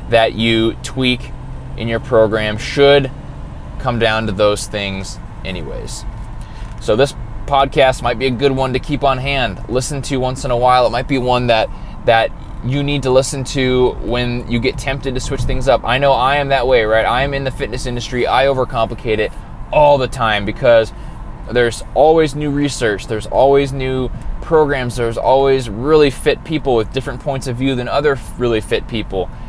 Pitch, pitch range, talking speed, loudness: 125 Hz, 115-135 Hz, 190 wpm, -16 LUFS